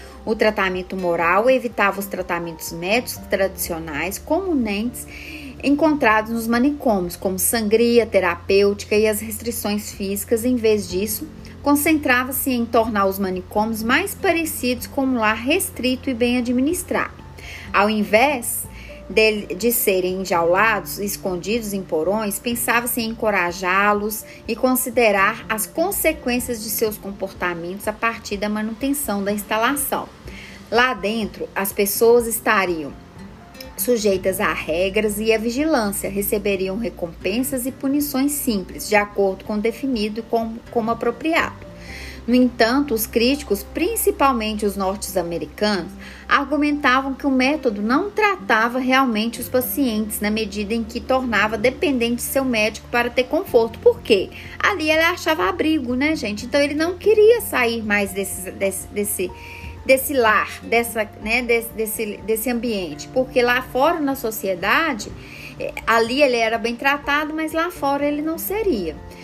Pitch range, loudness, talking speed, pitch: 205-265 Hz, -20 LUFS, 135 wpm, 230 Hz